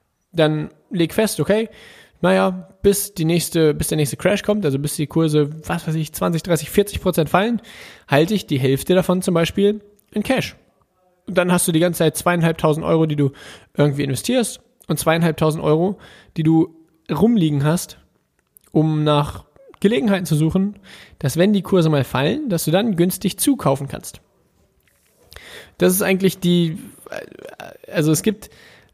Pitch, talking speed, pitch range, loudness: 170 Hz, 160 wpm, 155-195 Hz, -19 LUFS